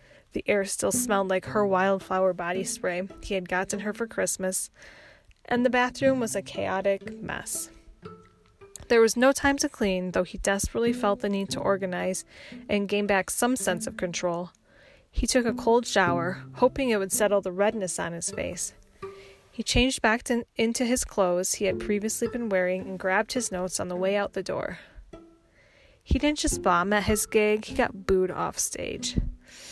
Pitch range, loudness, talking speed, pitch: 190-240 Hz, -26 LUFS, 185 wpm, 205 Hz